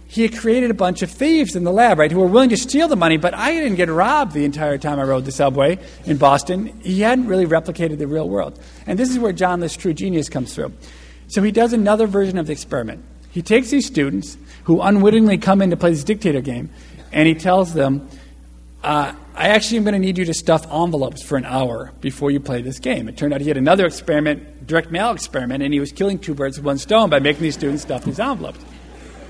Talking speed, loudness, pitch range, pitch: 245 wpm, -18 LUFS, 140-200 Hz, 165 Hz